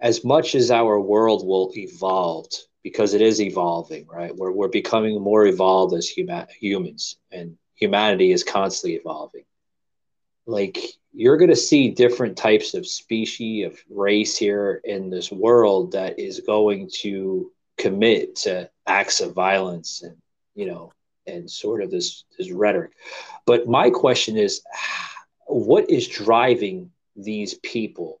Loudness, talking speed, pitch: -20 LUFS, 145 wpm, 125 Hz